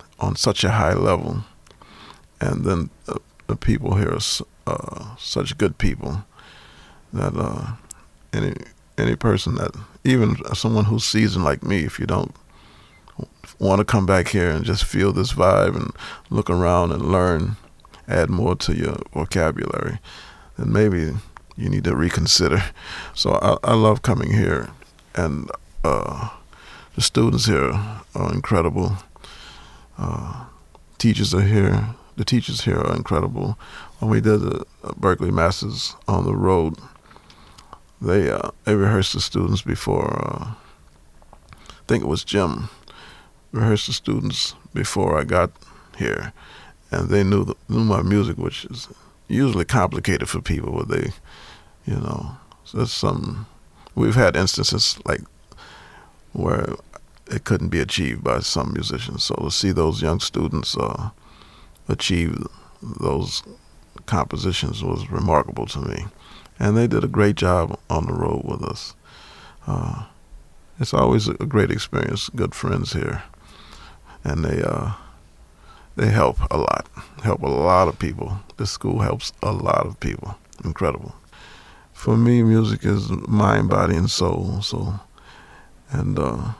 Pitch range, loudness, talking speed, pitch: 85-110 Hz, -21 LUFS, 140 wpm, 100 Hz